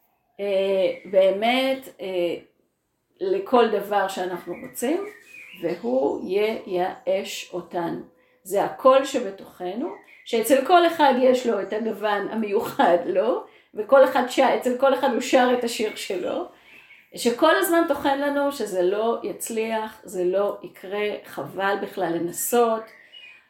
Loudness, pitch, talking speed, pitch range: -23 LUFS, 225 Hz, 110 wpm, 195-265 Hz